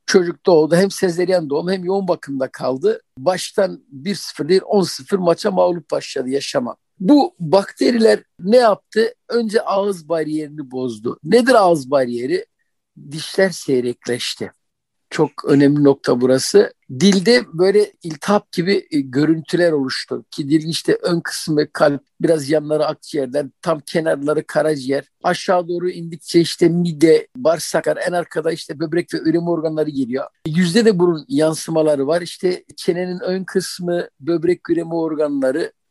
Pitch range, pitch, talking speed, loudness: 150-190 Hz, 170 Hz, 130 wpm, -18 LUFS